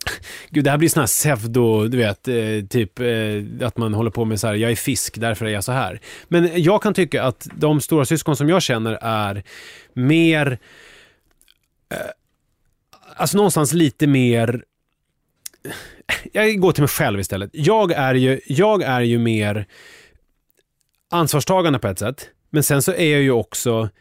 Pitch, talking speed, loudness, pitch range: 130 Hz, 165 wpm, -18 LUFS, 110-155 Hz